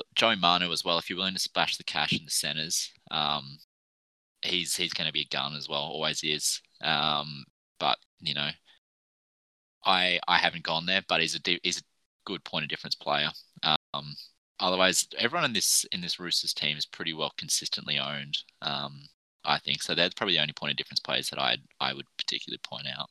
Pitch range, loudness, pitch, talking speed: 70-85 Hz, -28 LUFS, 75 Hz, 205 wpm